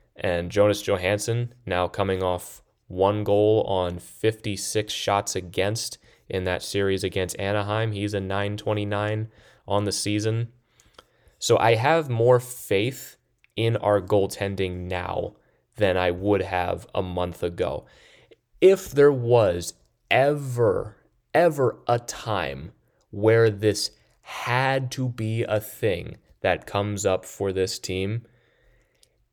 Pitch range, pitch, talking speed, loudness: 95-115 Hz, 105 Hz, 120 wpm, -24 LUFS